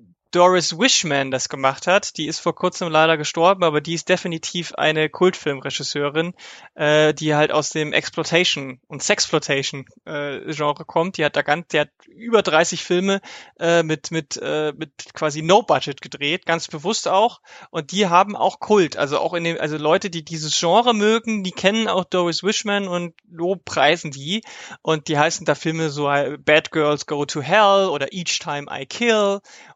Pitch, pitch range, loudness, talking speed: 165 Hz, 150-185 Hz, -20 LUFS, 175 wpm